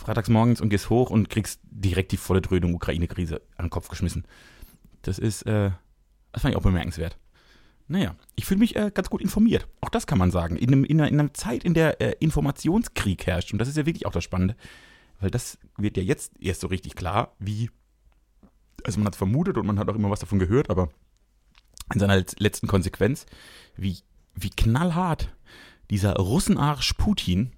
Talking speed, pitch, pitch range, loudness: 200 wpm, 100 Hz, 95-125 Hz, -25 LUFS